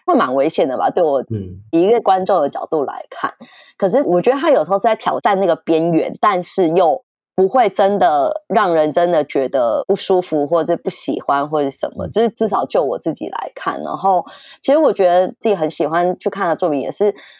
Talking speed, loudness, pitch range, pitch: 305 characters per minute, -17 LUFS, 165-230 Hz, 185 Hz